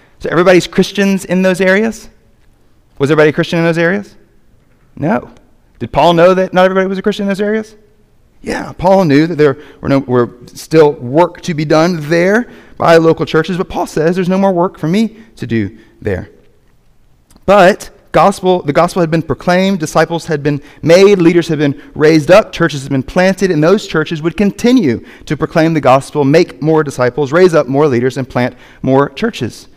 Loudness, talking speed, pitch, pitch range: -12 LUFS, 190 wpm, 170 Hz, 150-190 Hz